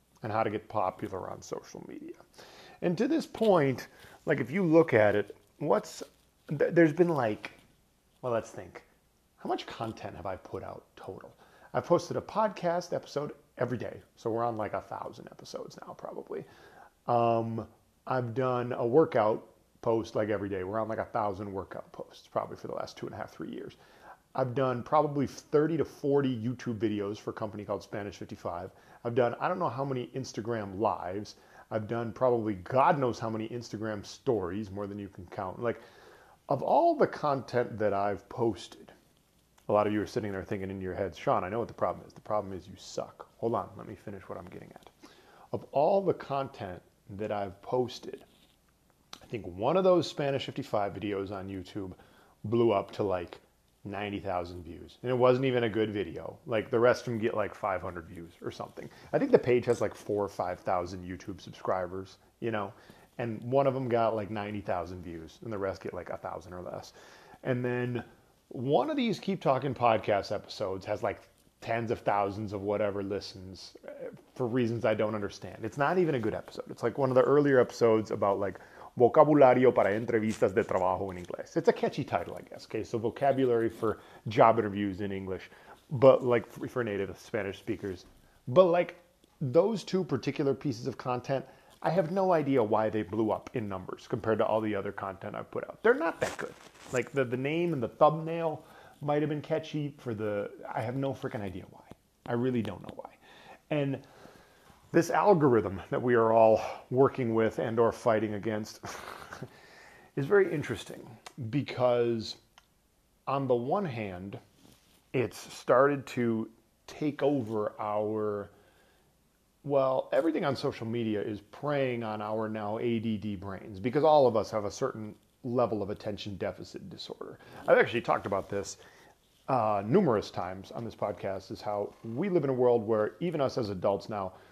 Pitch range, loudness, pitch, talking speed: 105-135 Hz, -30 LUFS, 115 Hz, 190 wpm